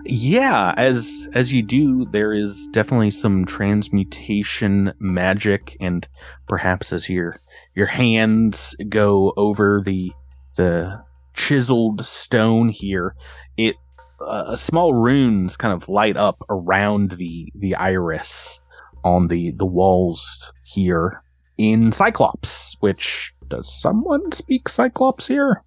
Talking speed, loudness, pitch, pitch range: 115 wpm, -19 LUFS, 100 Hz, 90-115 Hz